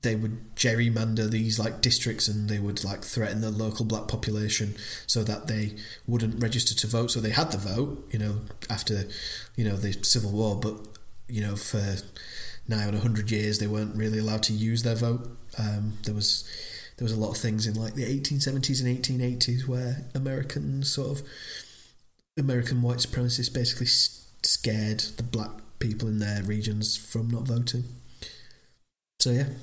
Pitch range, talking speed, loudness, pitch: 105-125 Hz, 175 wpm, -27 LUFS, 110 Hz